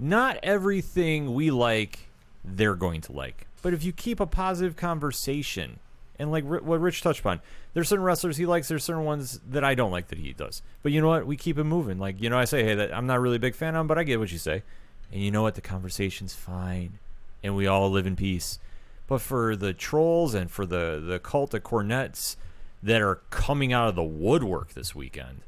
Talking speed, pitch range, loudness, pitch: 230 wpm, 95-160 Hz, -27 LUFS, 120 Hz